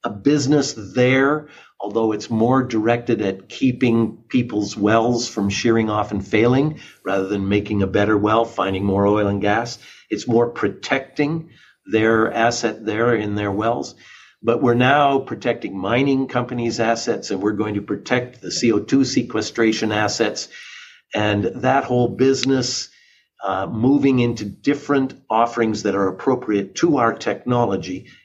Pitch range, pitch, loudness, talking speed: 105-125 Hz, 115 Hz, -20 LUFS, 140 wpm